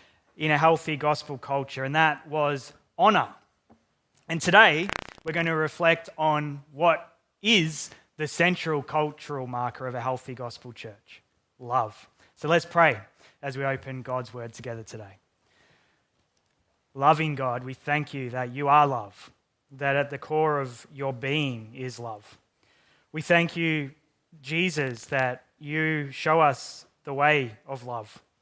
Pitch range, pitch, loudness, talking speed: 125-155 Hz, 145 Hz, -25 LUFS, 145 wpm